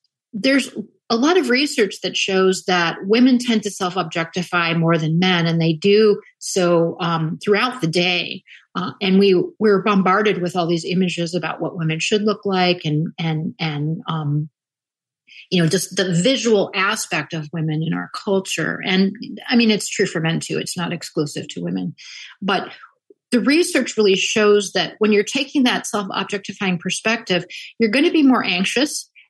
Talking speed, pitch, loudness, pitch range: 170 wpm, 185 Hz, -19 LUFS, 170-215 Hz